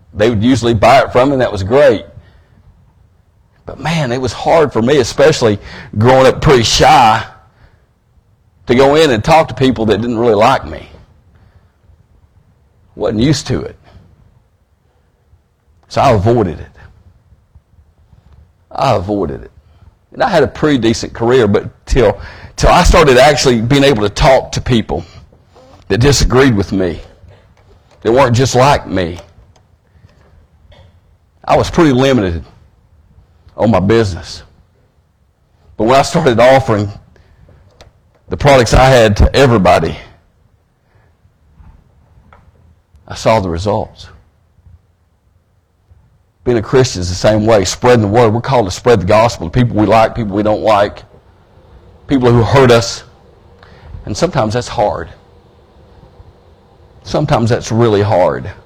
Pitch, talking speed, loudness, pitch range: 100 Hz, 135 wpm, -11 LUFS, 90-120 Hz